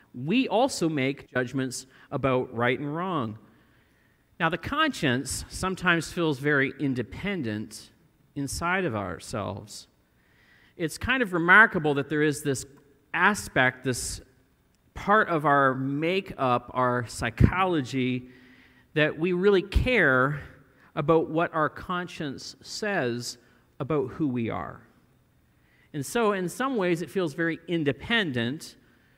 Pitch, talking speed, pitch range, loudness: 140 Hz, 115 wpm, 125-170 Hz, -26 LUFS